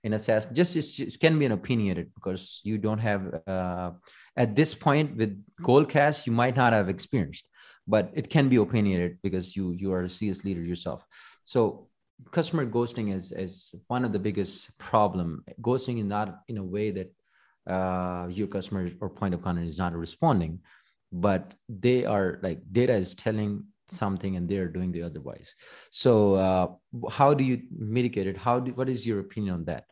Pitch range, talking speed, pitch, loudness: 95-120 Hz, 185 wpm, 105 Hz, -28 LUFS